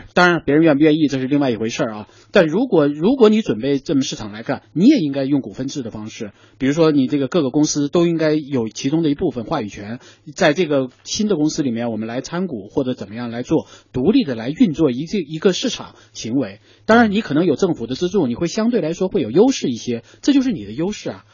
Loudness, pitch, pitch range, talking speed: -18 LUFS, 150 Hz, 125-180 Hz, 370 characters per minute